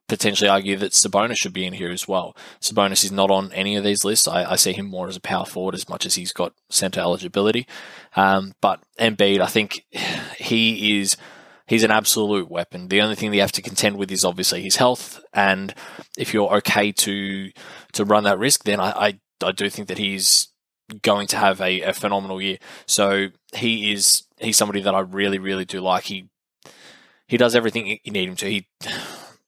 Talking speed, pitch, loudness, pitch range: 200 wpm, 100 Hz, -20 LUFS, 95-105 Hz